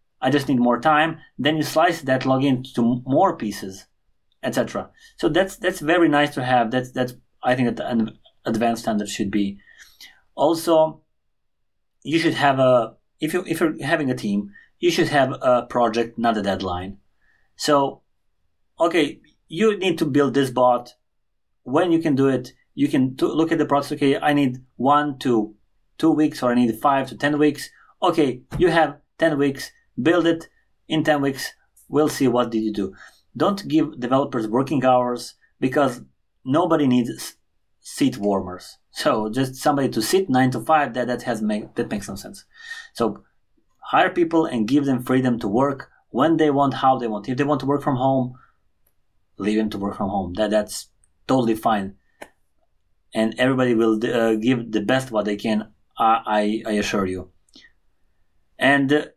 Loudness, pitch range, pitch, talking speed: -21 LUFS, 110-150 Hz, 130 Hz, 180 wpm